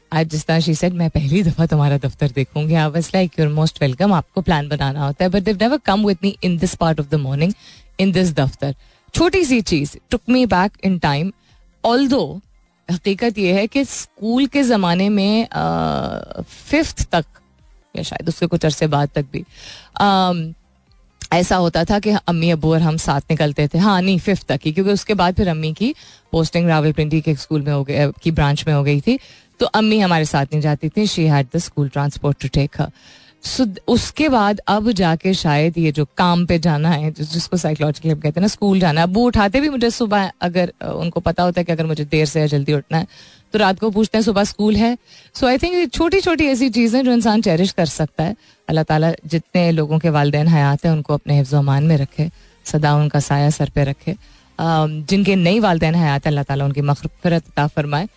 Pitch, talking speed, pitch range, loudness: 165 Hz, 205 wpm, 150-200 Hz, -17 LUFS